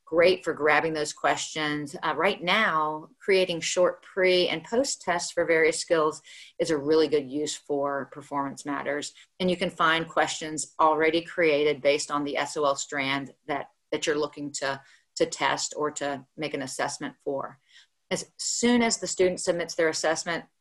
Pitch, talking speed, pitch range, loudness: 155 Hz, 170 wpm, 145-175 Hz, -26 LUFS